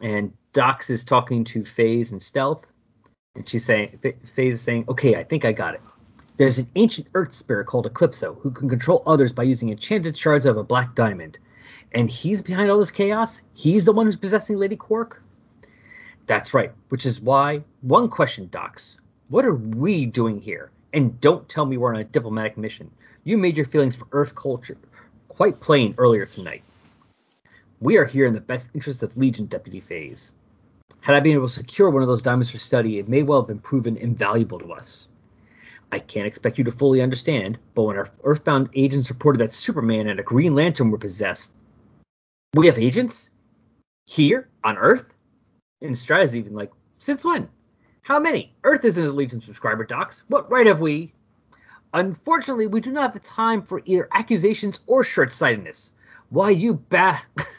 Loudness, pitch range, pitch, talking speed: -21 LUFS, 115-180 Hz, 135 Hz, 185 wpm